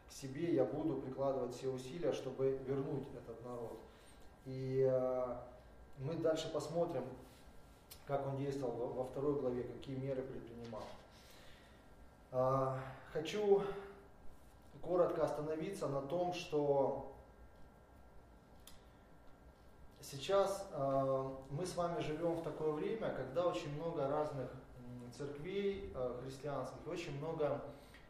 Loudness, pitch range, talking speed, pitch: -40 LUFS, 130-155 Hz, 105 wpm, 135 Hz